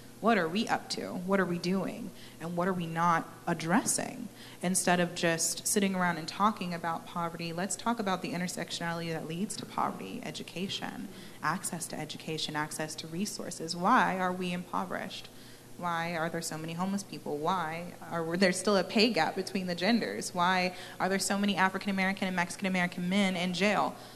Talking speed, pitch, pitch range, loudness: 185 wpm, 180 Hz, 170-195 Hz, -31 LUFS